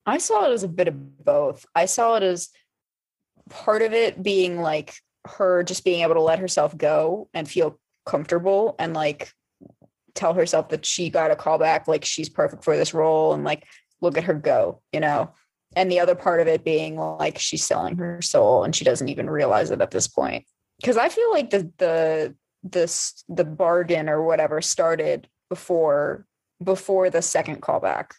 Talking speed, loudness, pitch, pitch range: 190 wpm, -22 LUFS, 175 Hz, 155-195 Hz